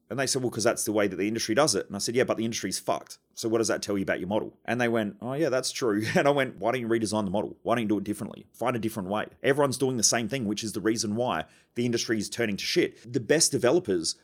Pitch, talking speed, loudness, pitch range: 115 Hz, 315 wpm, -27 LUFS, 110-125 Hz